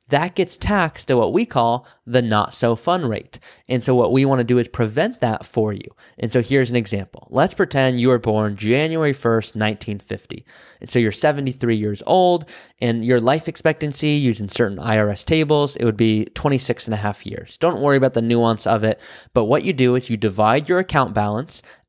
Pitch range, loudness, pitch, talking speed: 110-145 Hz, -19 LUFS, 125 Hz, 205 wpm